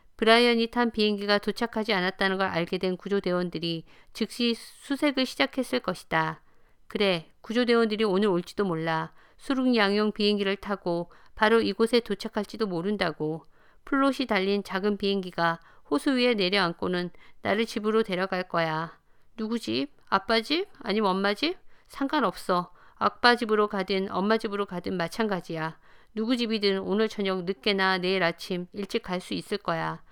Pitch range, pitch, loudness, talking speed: 180-225 Hz, 200 Hz, -27 LUFS, 335 characters per minute